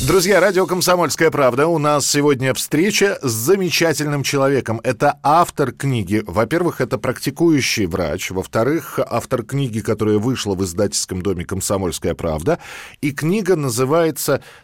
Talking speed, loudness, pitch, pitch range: 125 wpm, -18 LUFS, 135 Hz, 110-160 Hz